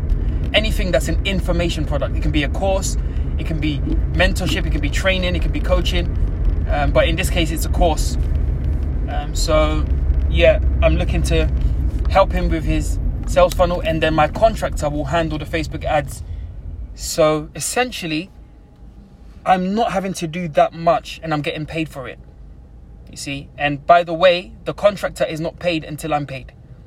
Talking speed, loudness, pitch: 180 wpm, -19 LUFS, 85 Hz